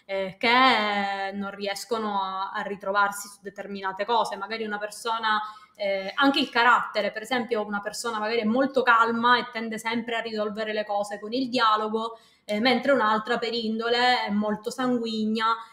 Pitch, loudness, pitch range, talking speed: 220 Hz, -25 LUFS, 205-235 Hz, 165 wpm